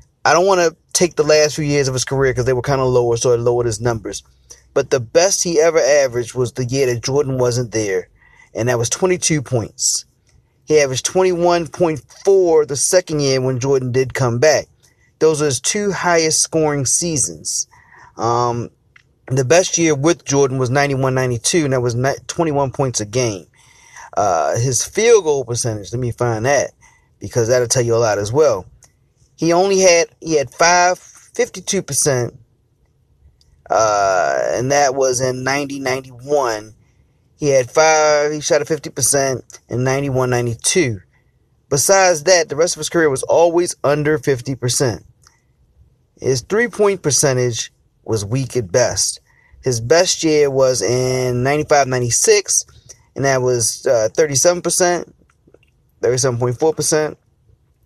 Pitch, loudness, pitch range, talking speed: 135 Hz, -16 LUFS, 125-160 Hz, 155 wpm